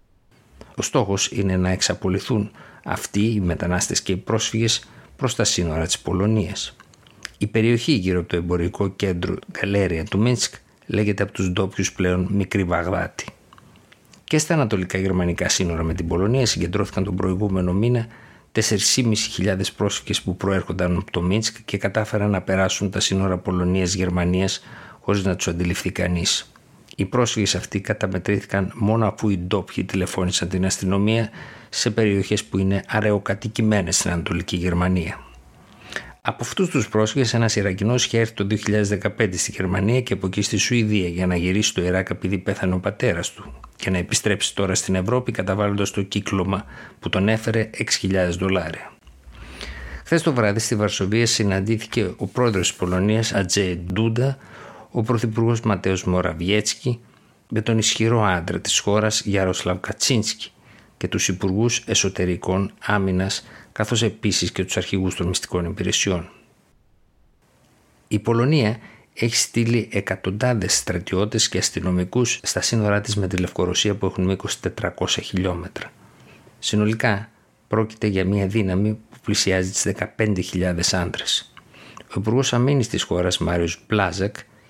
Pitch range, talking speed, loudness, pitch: 90-110 Hz, 140 wpm, -22 LUFS, 100 Hz